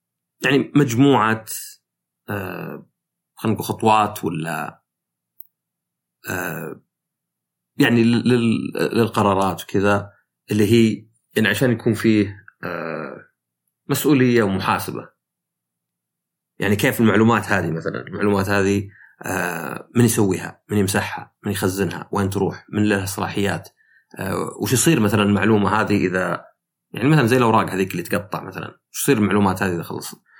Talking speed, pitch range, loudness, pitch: 105 wpm, 95-115 Hz, -20 LUFS, 105 Hz